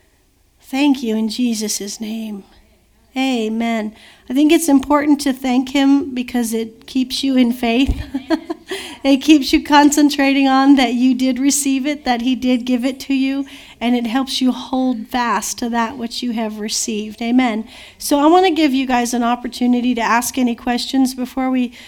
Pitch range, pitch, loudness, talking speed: 235-275 Hz, 255 Hz, -17 LUFS, 175 wpm